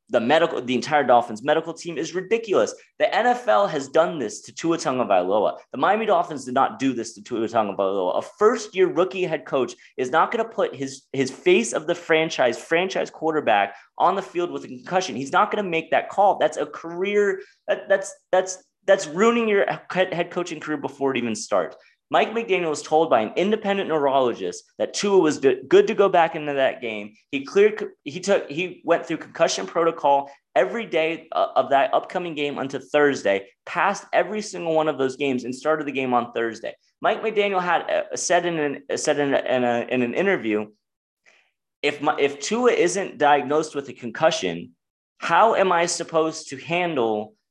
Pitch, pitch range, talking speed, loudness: 165 Hz, 140-195 Hz, 195 wpm, -22 LUFS